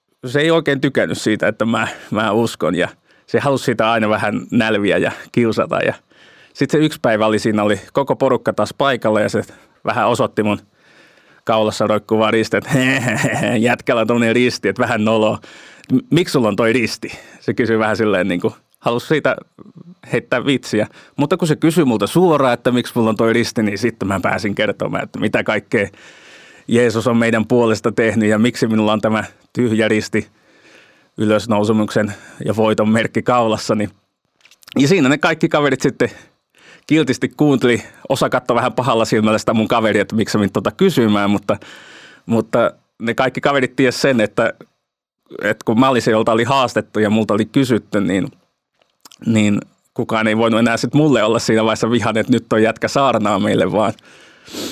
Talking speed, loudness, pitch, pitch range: 170 wpm, -16 LUFS, 115 Hz, 110-125 Hz